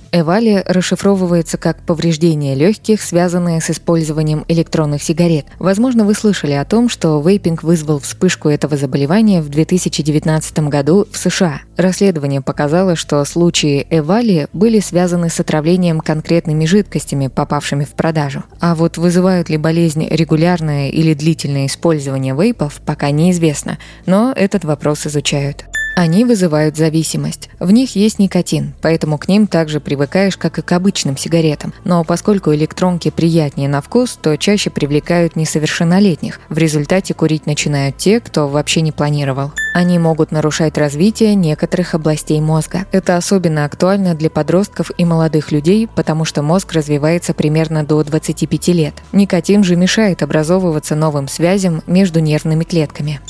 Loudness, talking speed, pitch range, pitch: -14 LUFS, 140 wpm, 155-185 Hz, 165 Hz